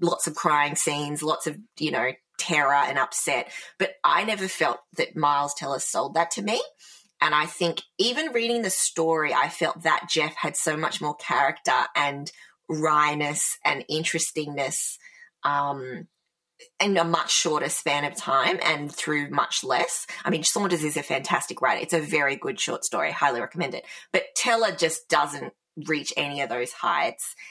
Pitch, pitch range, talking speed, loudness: 170 Hz, 150-175 Hz, 170 wpm, -24 LUFS